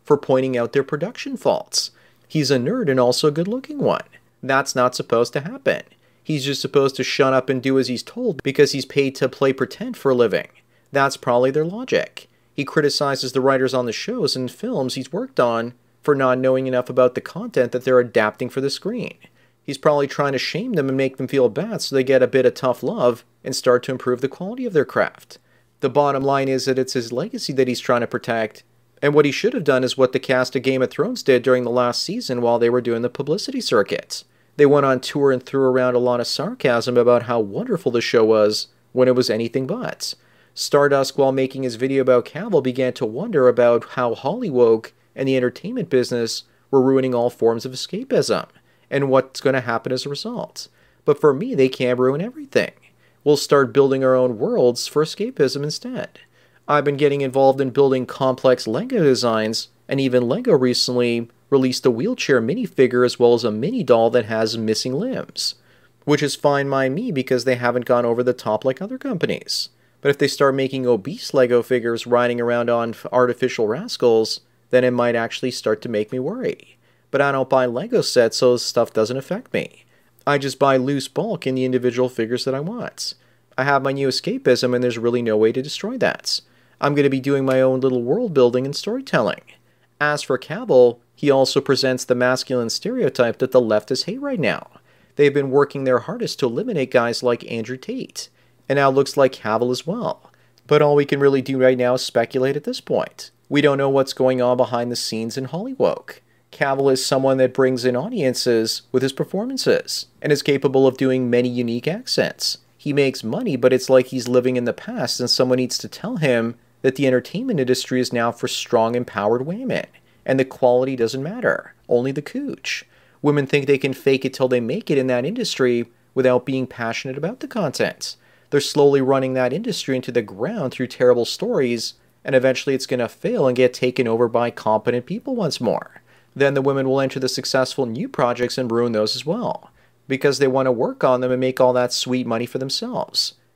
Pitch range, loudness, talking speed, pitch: 125-140 Hz, -20 LUFS, 210 wpm, 130 Hz